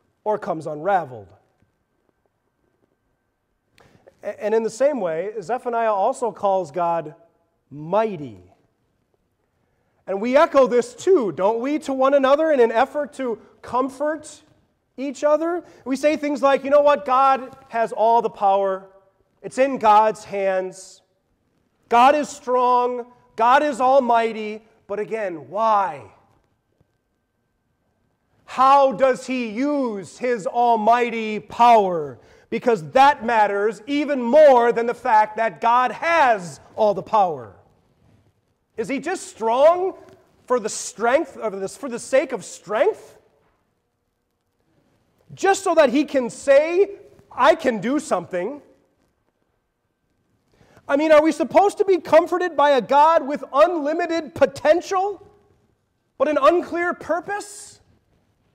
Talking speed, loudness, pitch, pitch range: 120 wpm, -19 LUFS, 250 Hz, 215-295 Hz